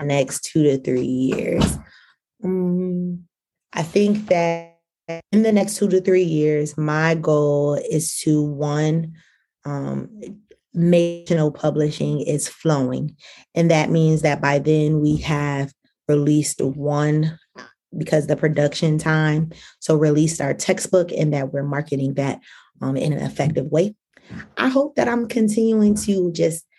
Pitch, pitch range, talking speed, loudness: 155 Hz, 145-180 Hz, 145 wpm, -20 LUFS